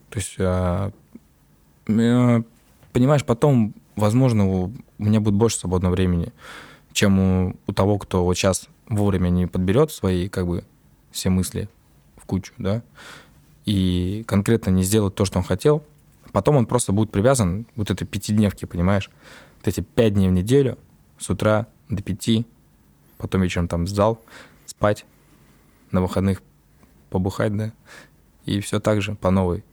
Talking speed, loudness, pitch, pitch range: 145 wpm, -22 LUFS, 100 Hz, 90-110 Hz